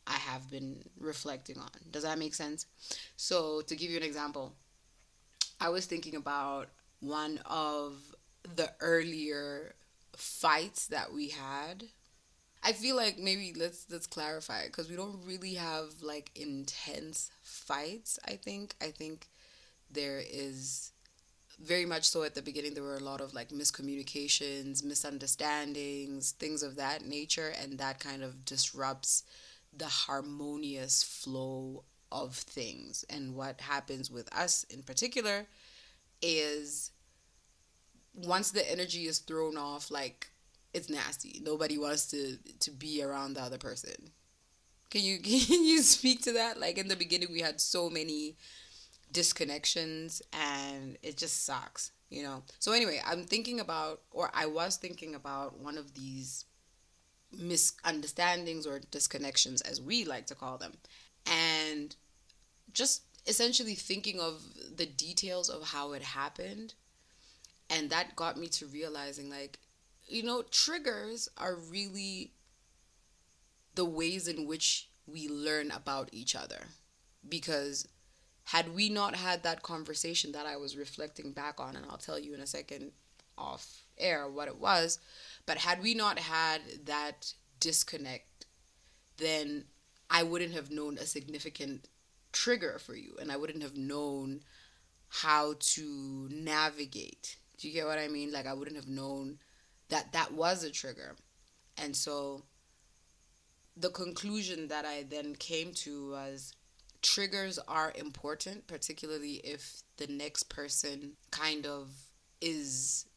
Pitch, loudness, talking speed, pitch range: 150 Hz, -34 LUFS, 140 wpm, 140-165 Hz